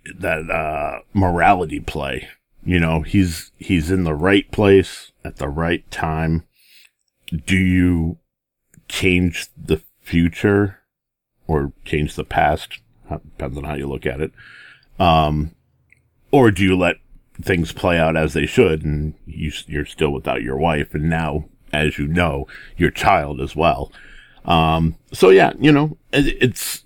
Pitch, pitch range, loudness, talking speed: 80 Hz, 75-95 Hz, -19 LUFS, 145 wpm